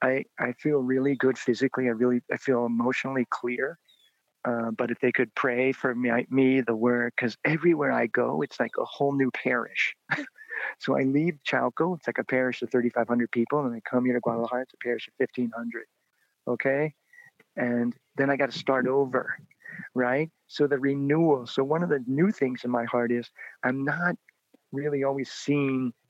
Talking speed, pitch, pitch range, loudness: 190 wpm, 130 Hz, 120-140 Hz, -27 LUFS